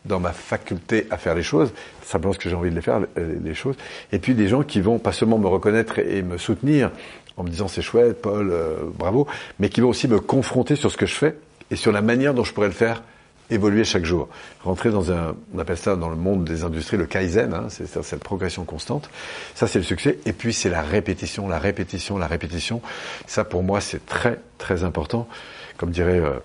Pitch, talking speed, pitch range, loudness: 100 Hz, 235 wpm, 90-115 Hz, -23 LUFS